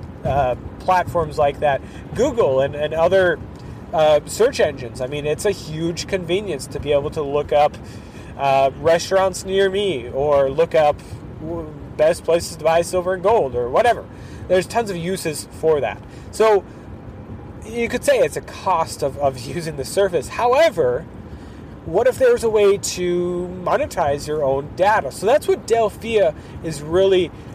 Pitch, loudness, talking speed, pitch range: 165 Hz, -19 LUFS, 160 wpm, 140-190 Hz